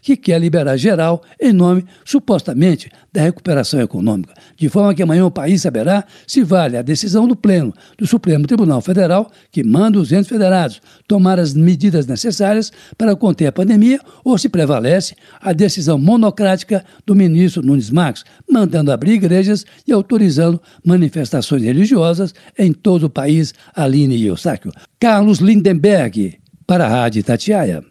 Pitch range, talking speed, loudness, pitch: 160-205 Hz, 150 wpm, -14 LUFS, 185 Hz